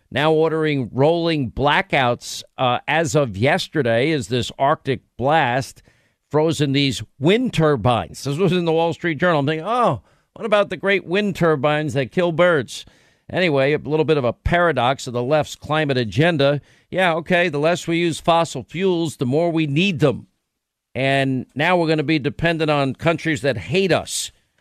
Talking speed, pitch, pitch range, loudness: 175 wpm, 155 Hz, 135-170 Hz, -19 LUFS